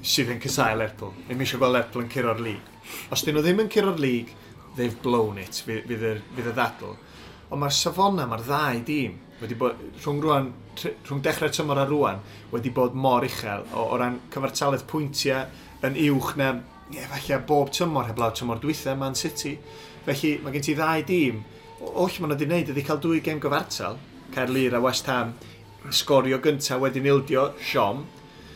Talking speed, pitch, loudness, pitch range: 175 wpm, 135 Hz, -25 LUFS, 120-150 Hz